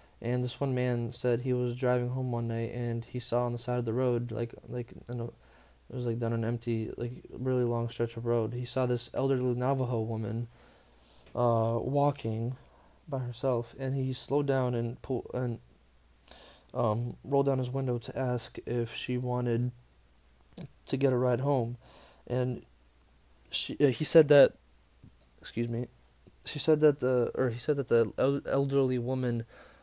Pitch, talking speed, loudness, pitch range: 120 Hz, 175 wpm, -31 LUFS, 115-130 Hz